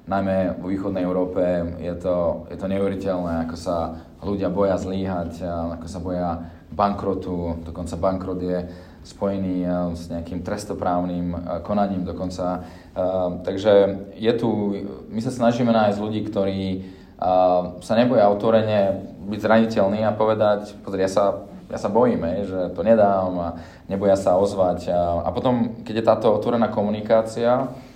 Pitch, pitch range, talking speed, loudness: 95 Hz, 90-105 Hz, 135 wpm, -22 LUFS